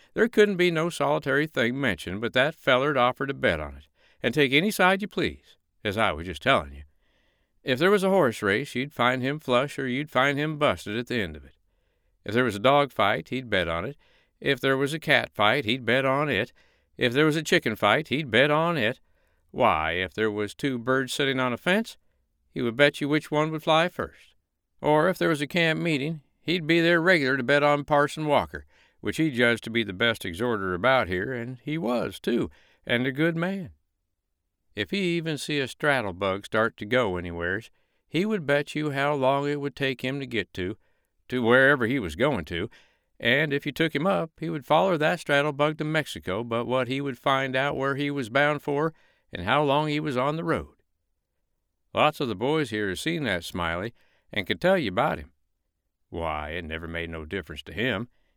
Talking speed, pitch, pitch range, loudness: 220 wpm, 135 Hz, 105-150 Hz, -25 LUFS